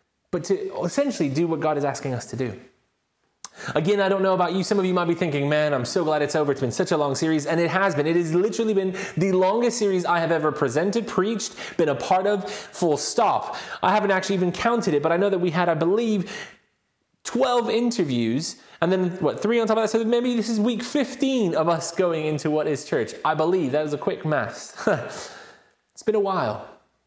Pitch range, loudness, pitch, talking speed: 155-215 Hz, -23 LUFS, 185 Hz, 235 wpm